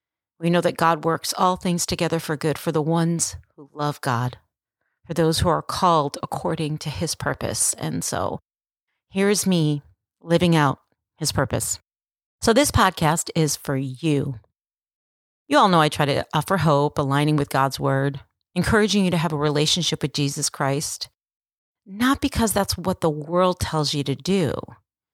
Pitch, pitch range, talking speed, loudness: 155 Hz, 140-170 Hz, 170 wpm, -22 LUFS